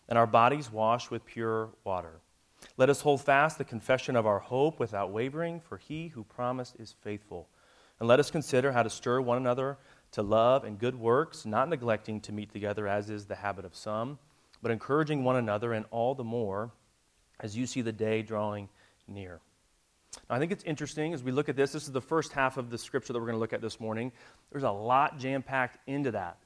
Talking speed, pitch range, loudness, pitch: 220 wpm, 105-135 Hz, -31 LUFS, 120 Hz